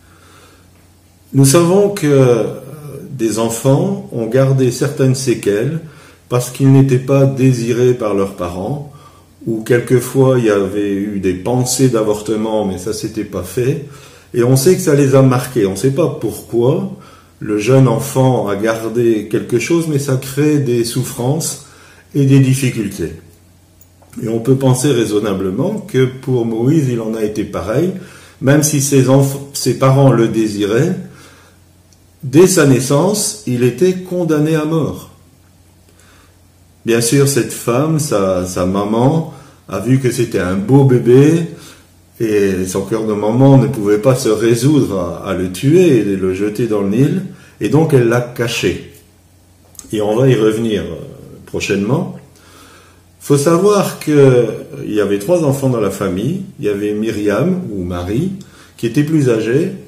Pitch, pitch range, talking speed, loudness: 120 Hz, 100-140 Hz, 155 wpm, -14 LUFS